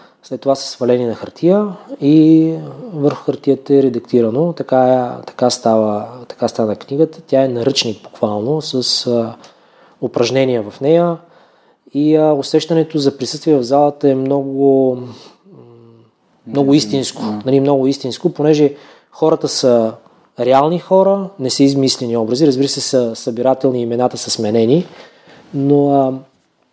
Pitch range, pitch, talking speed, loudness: 125-150 Hz, 135 Hz, 130 wpm, -15 LUFS